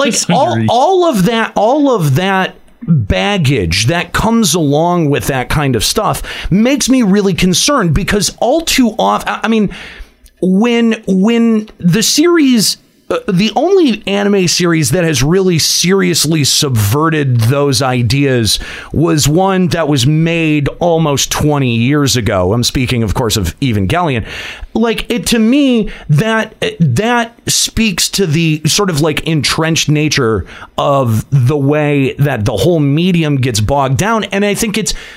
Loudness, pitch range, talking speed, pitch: -12 LUFS, 140-205 Hz, 145 wpm, 165 Hz